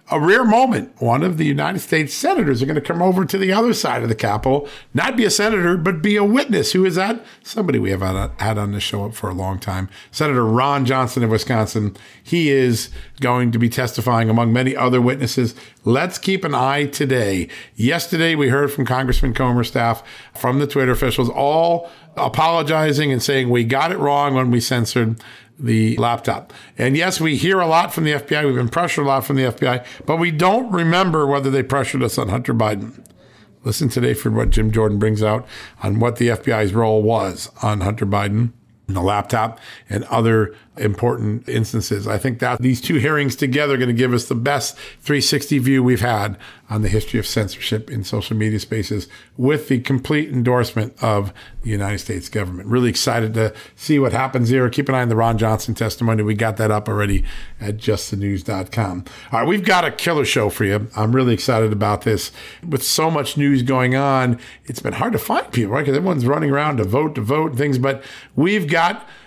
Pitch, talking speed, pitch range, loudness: 125 Hz, 210 wpm, 110-140 Hz, -18 LUFS